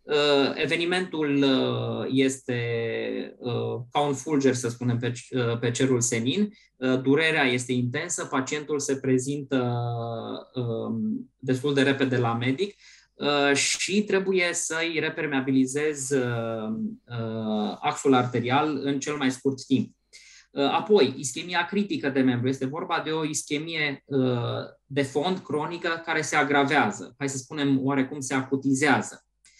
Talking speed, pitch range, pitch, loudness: 110 wpm, 125-150 Hz, 140 Hz, -26 LUFS